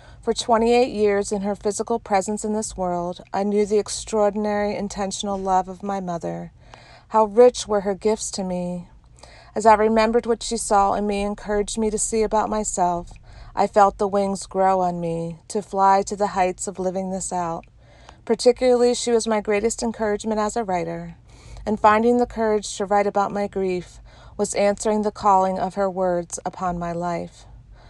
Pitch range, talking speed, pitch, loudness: 185-215 Hz, 185 wpm, 205 Hz, -22 LUFS